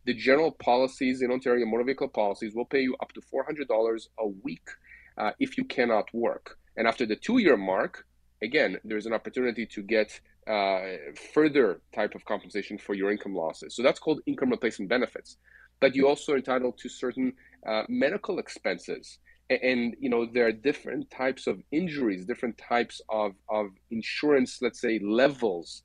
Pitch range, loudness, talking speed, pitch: 105-130 Hz, -28 LUFS, 170 wpm, 120 Hz